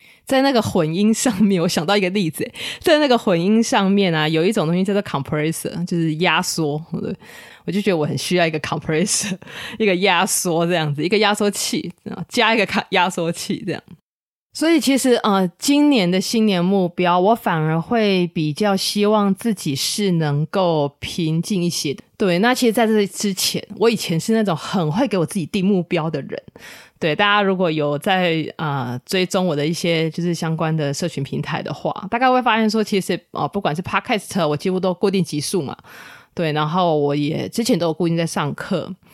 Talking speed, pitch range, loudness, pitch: 315 characters per minute, 165-210 Hz, -19 LUFS, 185 Hz